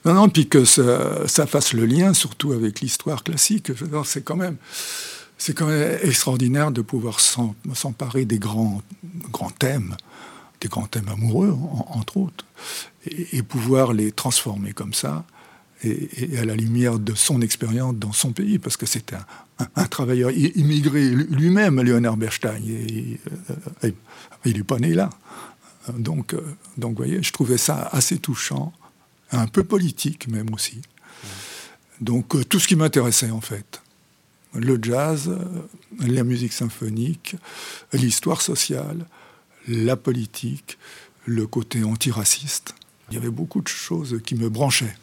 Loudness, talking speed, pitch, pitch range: -21 LUFS, 150 wpm, 130 Hz, 115-155 Hz